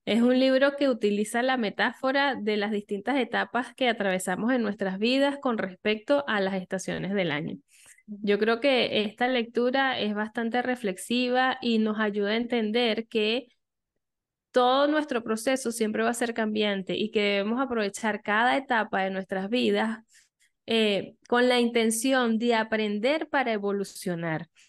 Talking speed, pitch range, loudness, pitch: 150 wpm, 205-250 Hz, -26 LUFS, 225 Hz